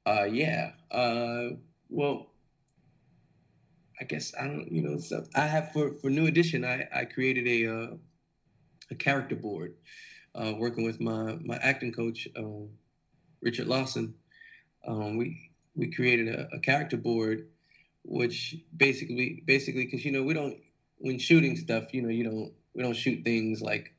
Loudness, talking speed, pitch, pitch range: -30 LUFS, 160 wpm, 125 Hz, 115-145 Hz